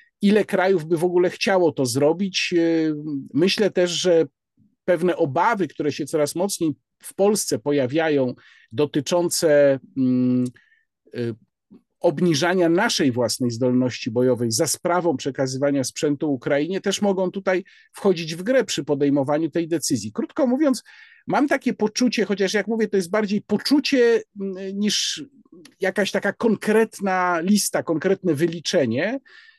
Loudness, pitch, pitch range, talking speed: -21 LUFS, 175 Hz, 150-205 Hz, 120 wpm